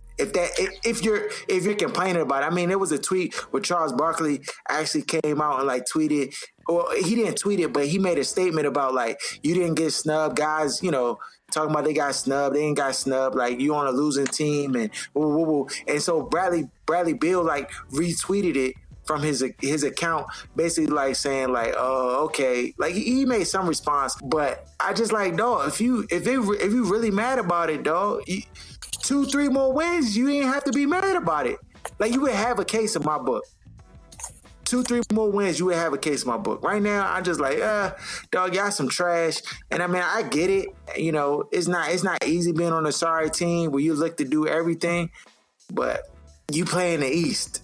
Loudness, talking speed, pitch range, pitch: -24 LUFS, 225 wpm, 150-215 Hz, 170 Hz